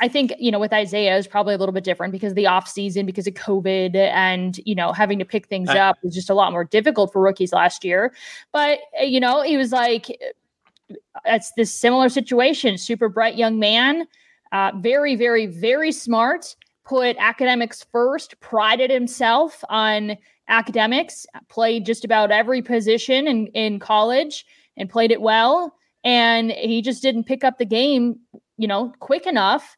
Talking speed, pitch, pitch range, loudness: 175 wpm, 230 Hz, 200-260 Hz, -19 LUFS